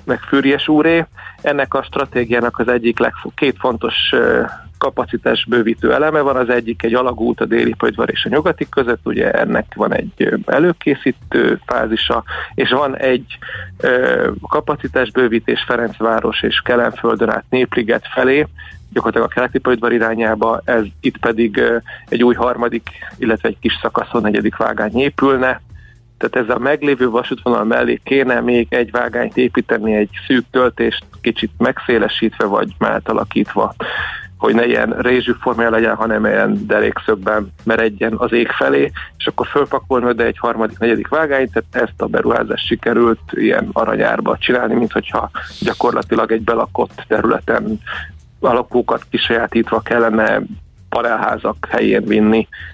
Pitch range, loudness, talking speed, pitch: 115-125 Hz, -16 LUFS, 135 wpm, 120 Hz